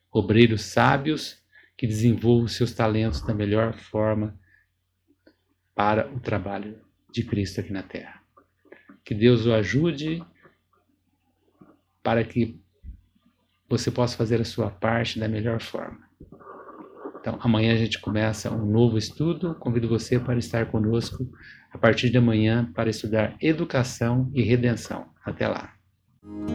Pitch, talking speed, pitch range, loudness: 115 Hz, 125 wpm, 110-120 Hz, -24 LUFS